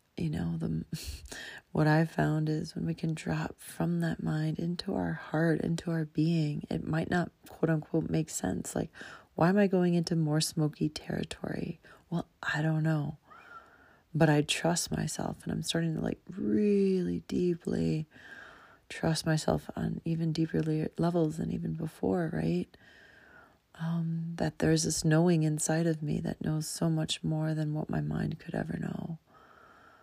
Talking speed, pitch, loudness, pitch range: 160 wpm, 160 Hz, -31 LUFS, 150-165 Hz